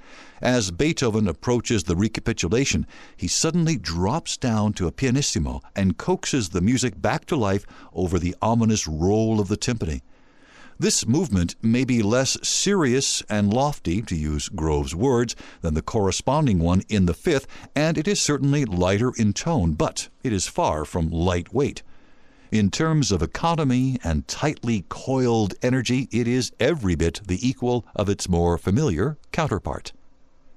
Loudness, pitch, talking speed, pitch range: -23 LUFS, 110 Hz, 150 wpm, 95-130 Hz